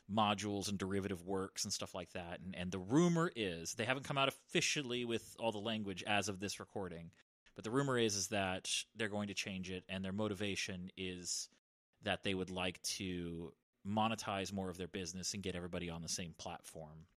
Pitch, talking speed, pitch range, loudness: 95 Hz, 205 wpm, 90-105 Hz, -40 LUFS